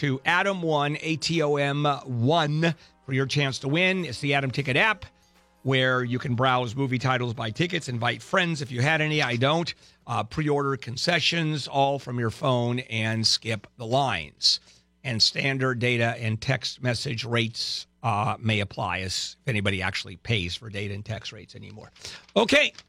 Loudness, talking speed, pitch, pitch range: -25 LUFS, 180 wpm, 130 Hz, 115-145 Hz